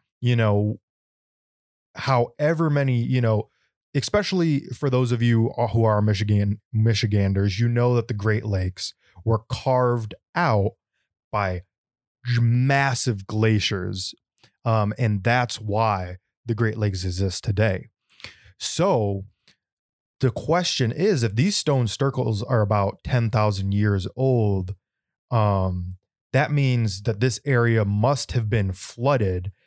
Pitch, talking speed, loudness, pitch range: 115 Hz, 120 wpm, -23 LUFS, 100-125 Hz